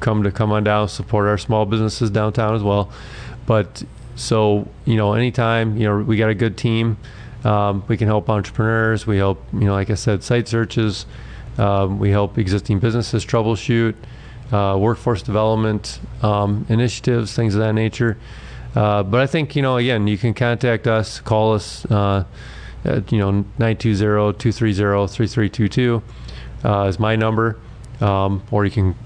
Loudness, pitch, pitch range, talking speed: -19 LUFS, 110 Hz, 105-115 Hz, 165 wpm